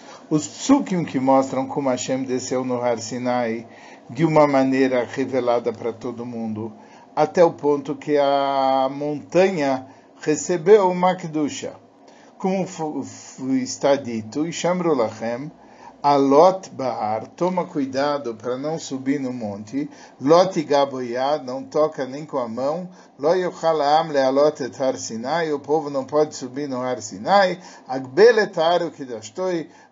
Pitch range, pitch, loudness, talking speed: 130-165 Hz, 140 Hz, -21 LUFS, 135 wpm